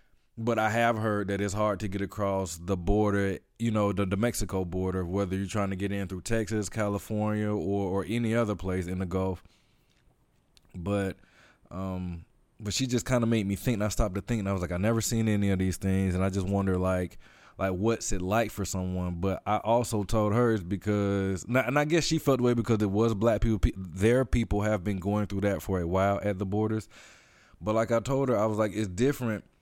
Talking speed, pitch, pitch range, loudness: 230 wpm, 105 Hz, 95-115 Hz, -29 LUFS